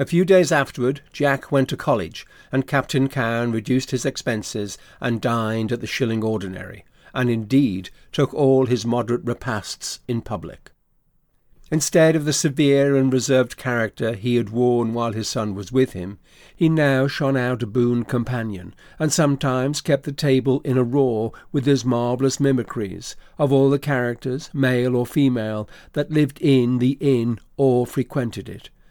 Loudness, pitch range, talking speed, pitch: -21 LUFS, 115-140 Hz, 165 wpm, 130 Hz